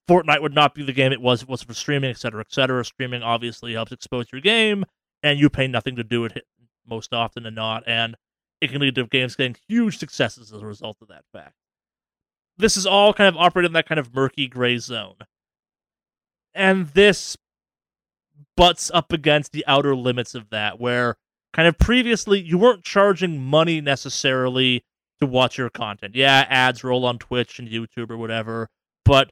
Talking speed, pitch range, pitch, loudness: 190 wpm, 120-155 Hz, 130 Hz, -20 LUFS